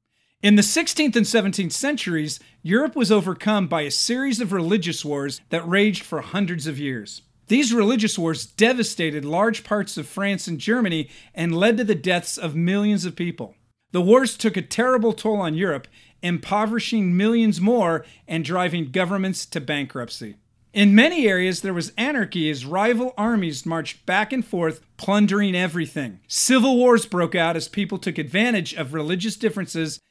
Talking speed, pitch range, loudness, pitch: 165 wpm, 160-215 Hz, -21 LUFS, 185 Hz